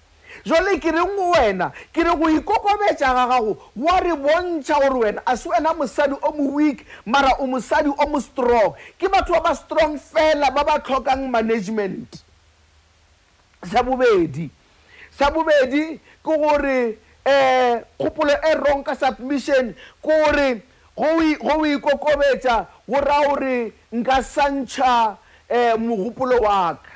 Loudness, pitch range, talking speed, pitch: -19 LUFS, 250-310 Hz, 135 wpm, 280 Hz